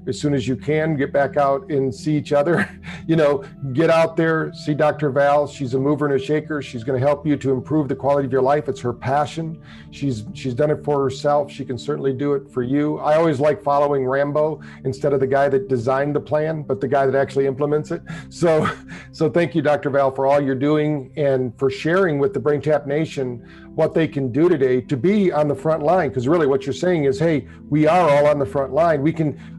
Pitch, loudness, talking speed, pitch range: 145 Hz, -20 LUFS, 240 wpm, 135-155 Hz